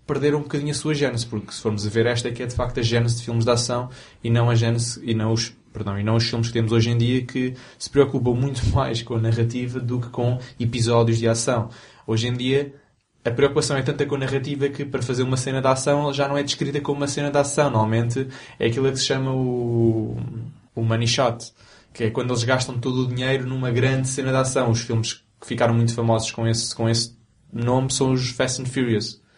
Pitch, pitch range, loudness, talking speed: 125 Hz, 115-135 Hz, -22 LUFS, 245 wpm